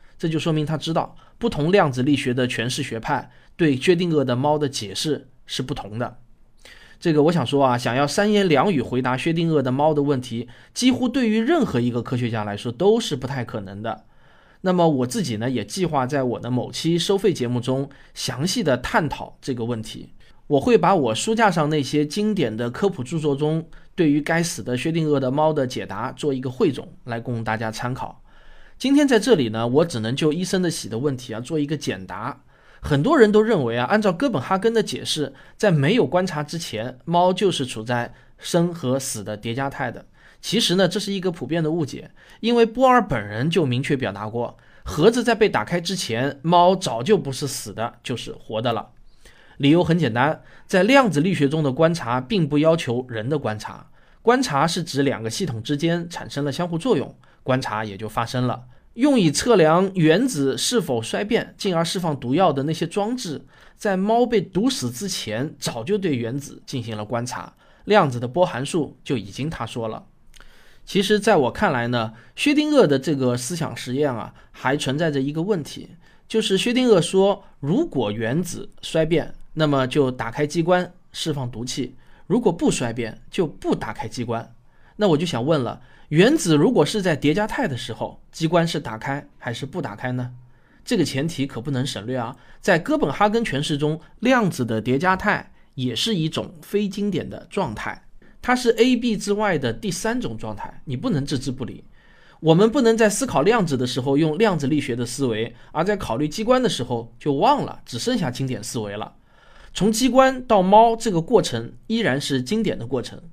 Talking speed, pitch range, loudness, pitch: 285 characters per minute, 125-185 Hz, -21 LUFS, 150 Hz